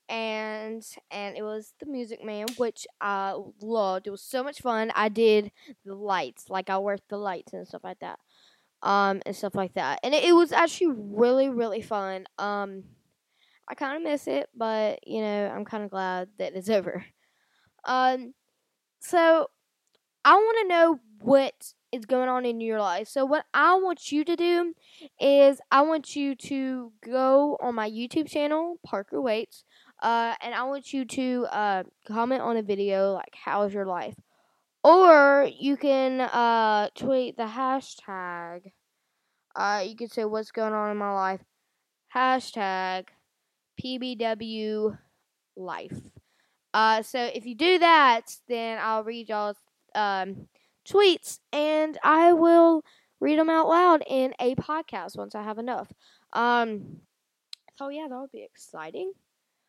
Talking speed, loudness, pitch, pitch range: 160 wpm, -25 LUFS, 235 Hz, 205-280 Hz